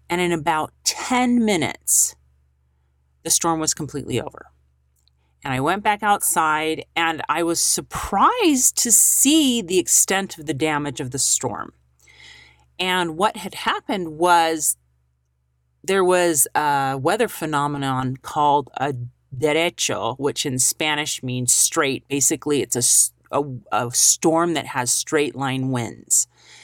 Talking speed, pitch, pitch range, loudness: 130 wpm, 145 Hz, 115-170 Hz, -19 LUFS